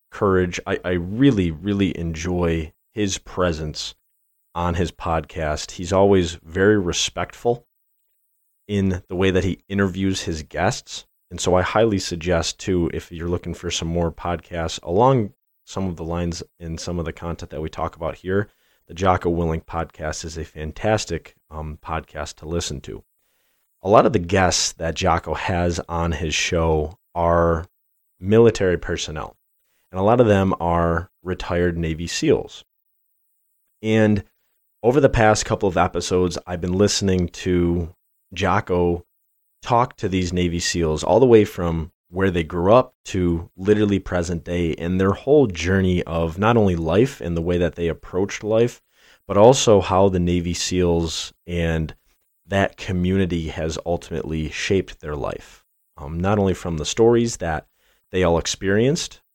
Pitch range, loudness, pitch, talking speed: 85-95 Hz, -21 LUFS, 90 Hz, 155 wpm